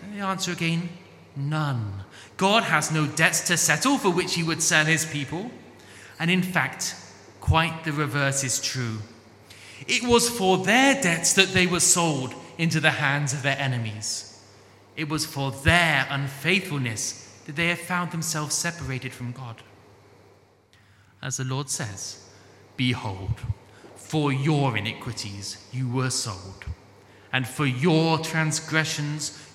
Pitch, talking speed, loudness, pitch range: 140 Hz, 140 wpm, -24 LUFS, 110-165 Hz